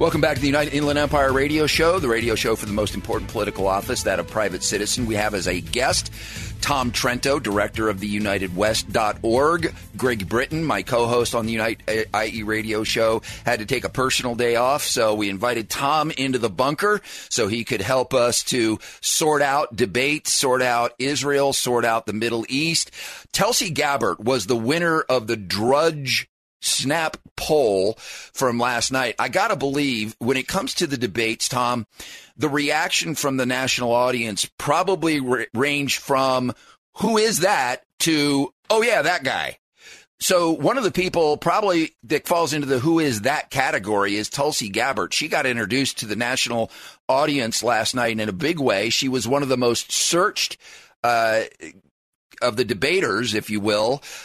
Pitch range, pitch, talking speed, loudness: 110-145 Hz, 125 Hz, 180 wpm, -21 LUFS